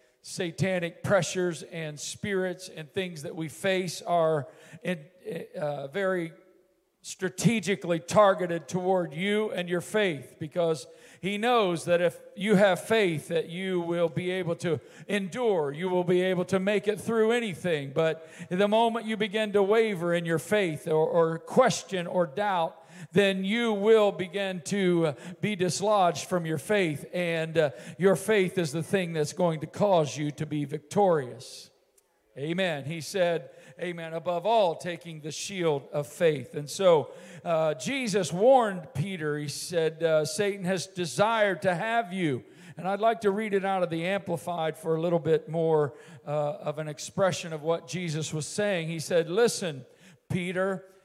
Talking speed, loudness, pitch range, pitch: 160 wpm, -28 LUFS, 160-195 Hz, 175 Hz